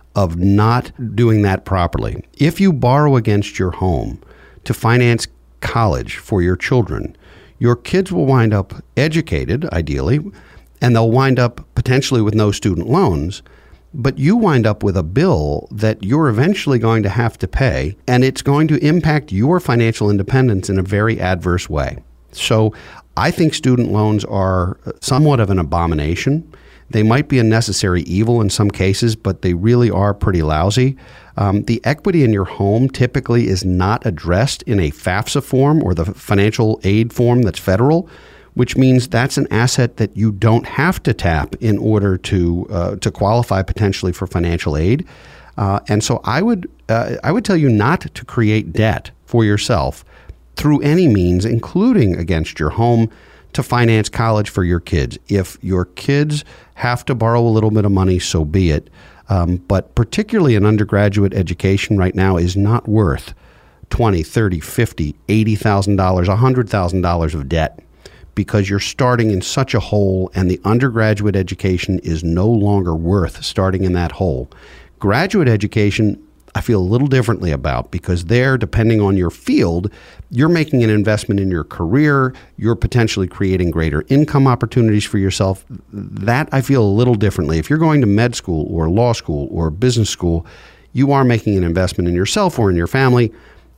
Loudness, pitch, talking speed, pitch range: -16 LUFS, 105 Hz, 175 wpm, 95-125 Hz